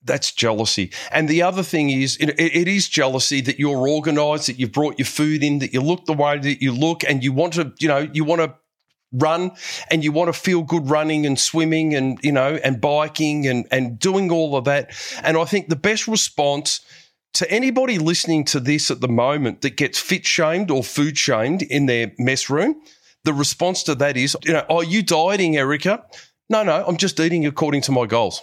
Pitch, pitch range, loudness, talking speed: 150 Hz, 140-165 Hz, -19 LUFS, 215 wpm